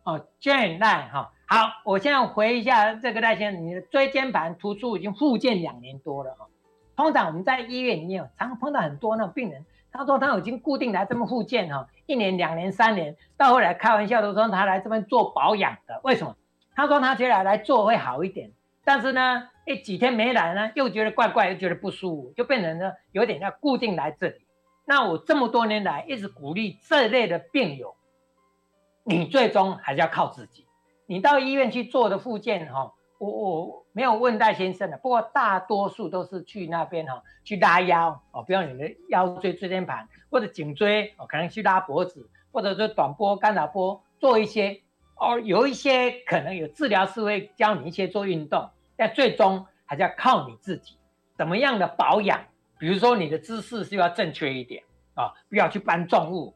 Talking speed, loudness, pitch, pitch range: 300 characters per minute, -24 LUFS, 205 Hz, 175-245 Hz